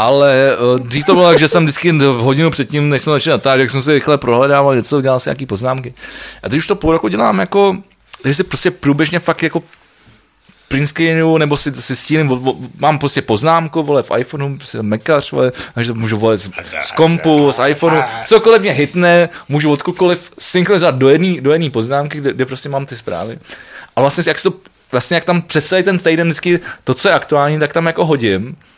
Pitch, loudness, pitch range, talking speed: 145 Hz, -13 LUFS, 135-165 Hz, 200 wpm